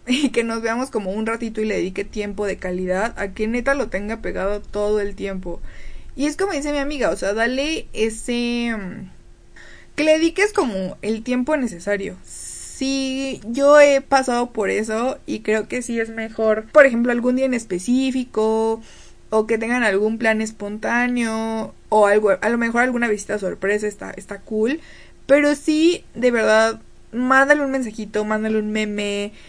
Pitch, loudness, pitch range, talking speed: 225 Hz, -20 LUFS, 210-255 Hz, 170 wpm